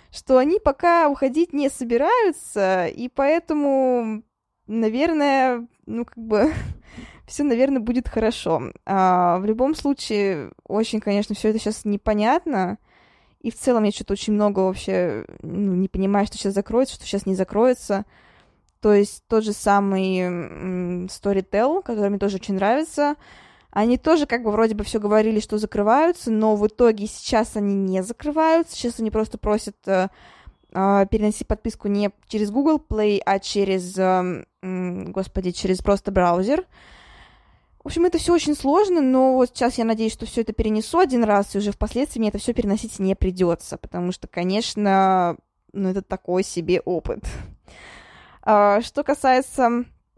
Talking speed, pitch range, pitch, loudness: 155 wpm, 195-250 Hz, 215 Hz, -21 LUFS